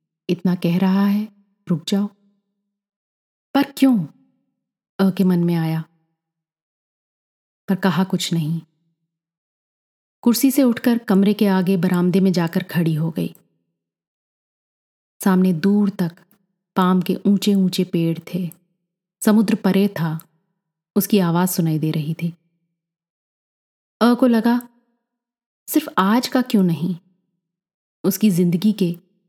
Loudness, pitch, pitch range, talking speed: -19 LUFS, 185 Hz, 170-205 Hz, 120 wpm